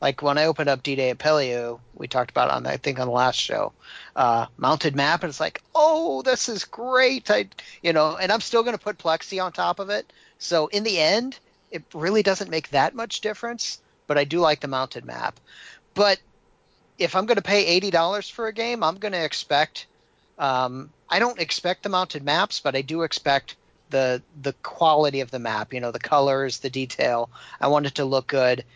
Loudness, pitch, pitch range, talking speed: -23 LUFS, 155 Hz, 135-200 Hz, 215 wpm